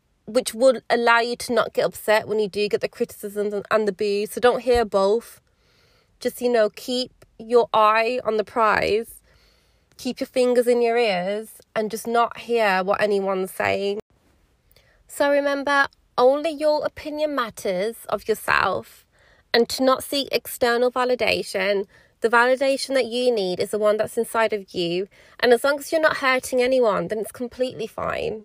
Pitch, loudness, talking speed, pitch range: 235 Hz, -22 LUFS, 170 wpm, 215-255 Hz